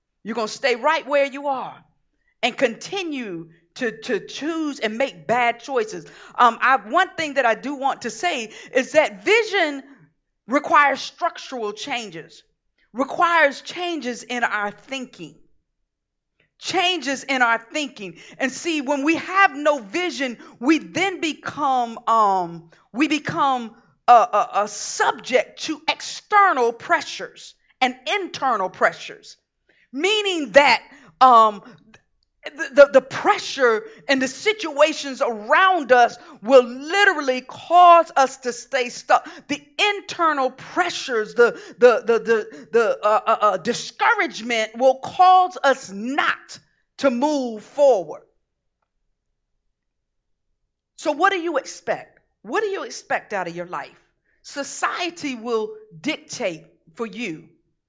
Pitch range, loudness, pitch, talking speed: 235-335 Hz, -20 LUFS, 275 Hz, 125 wpm